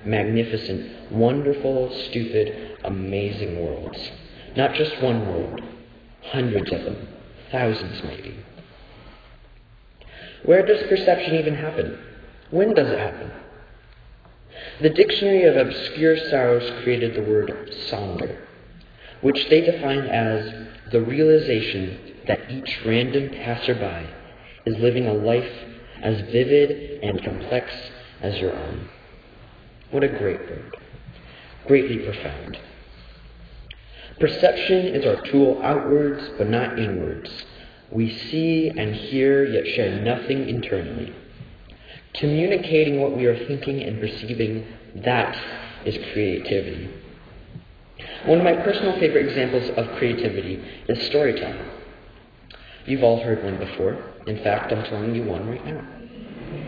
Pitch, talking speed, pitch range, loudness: 120 Hz, 115 wpm, 110-140 Hz, -22 LUFS